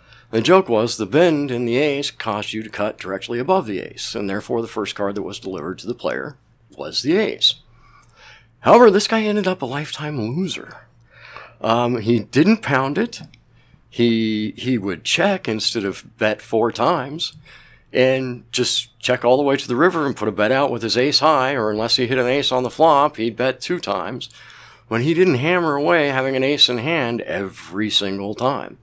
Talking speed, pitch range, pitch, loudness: 200 wpm, 110-145 Hz, 125 Hz, -19 LUFS